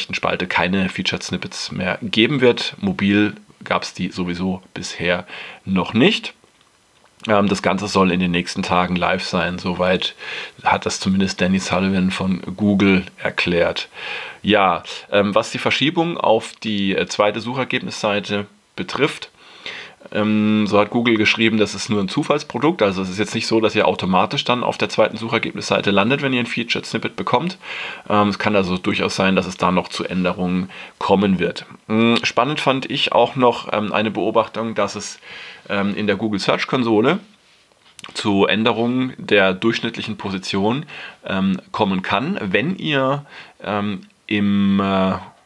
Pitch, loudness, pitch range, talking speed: 100 Hz, -19 LUFS, 95-110 Hz, 145 wpm